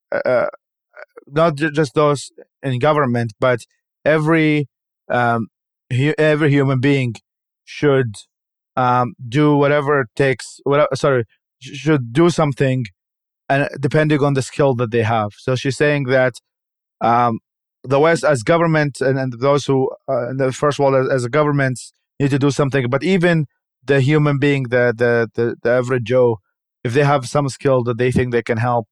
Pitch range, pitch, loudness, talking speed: 125-150 Hz, 135 Hz, -17 LUFS, 160 wpm